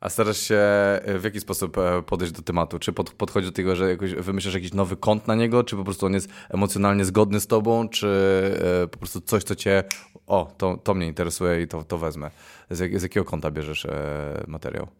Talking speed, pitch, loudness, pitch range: 200 wpm, 95 Hz, -24 LUFS, 90-100 Hz